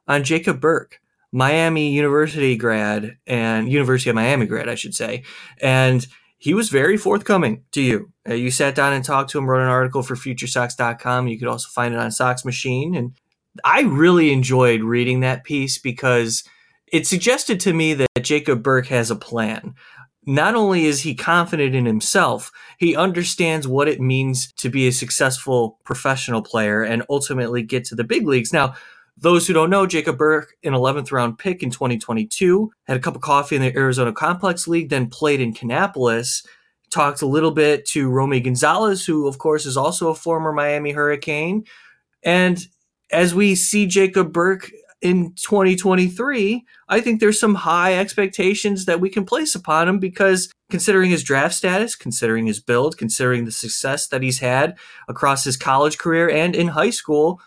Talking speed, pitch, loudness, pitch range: 175 wpm, 145 Hz, -18 LUFS, 125-175 Hz